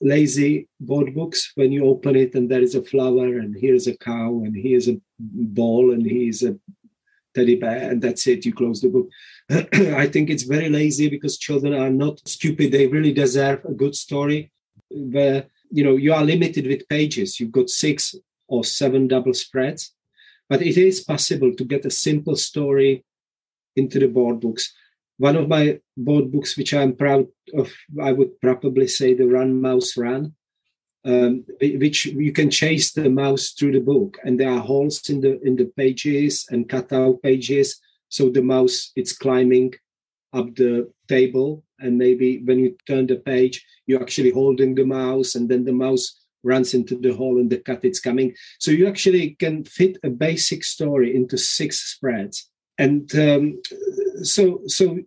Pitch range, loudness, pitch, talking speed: 130-150 Hz, -19 LUFS, 135 Hz, 180 wpm